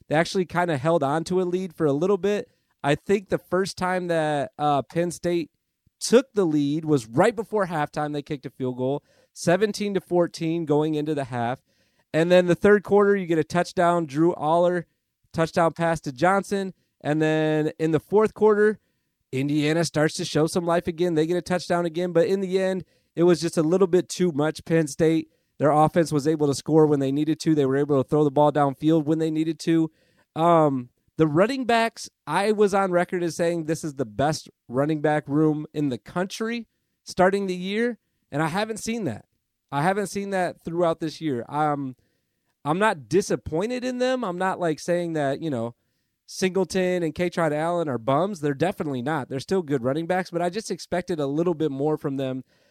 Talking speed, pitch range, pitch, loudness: 210 wpm, 150-185 Hz, 165 Hz, -24 LUFS